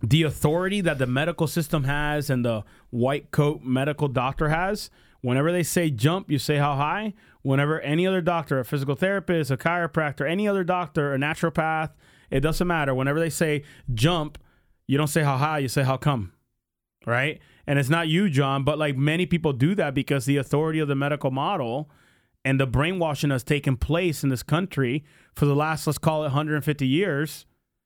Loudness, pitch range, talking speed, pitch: -24 LUFS, 140-165 Hz, 190 wpm, 150 Hz